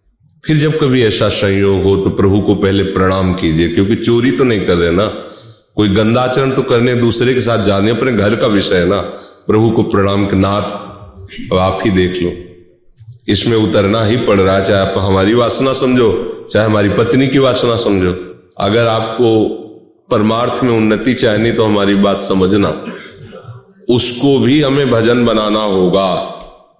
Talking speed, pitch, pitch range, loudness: 170 wpm, 110 Hz, 95-120 Hz, -12 LUFS